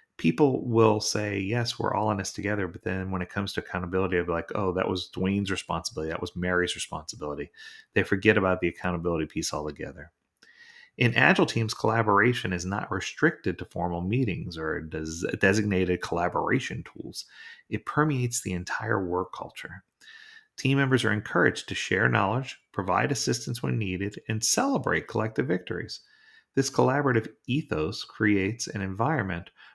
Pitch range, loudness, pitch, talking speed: 90-125 Hz, -27 LUFS, 100 Hz, 155 wpm